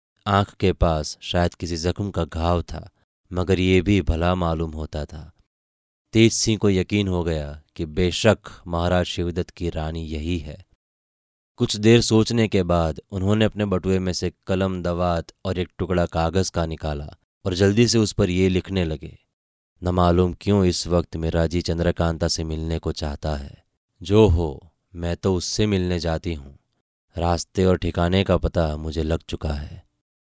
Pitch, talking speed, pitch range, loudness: 85 Hz, 170 wpm, 80-95 Hz, -22 LUFS